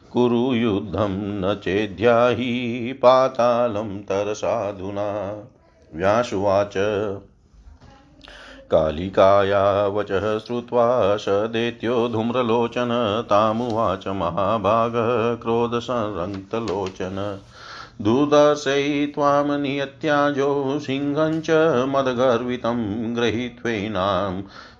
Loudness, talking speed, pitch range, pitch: -21 LUFS, 45 wpm, 100-125 Hz, 120 Hz